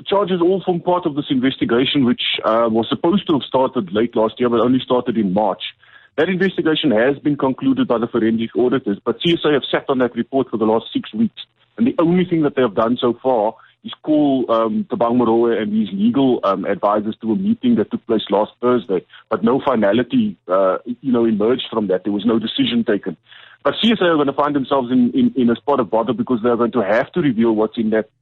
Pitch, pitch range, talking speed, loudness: 130 Hz, 115-170 Hz, 230 wpm, -18 LUFS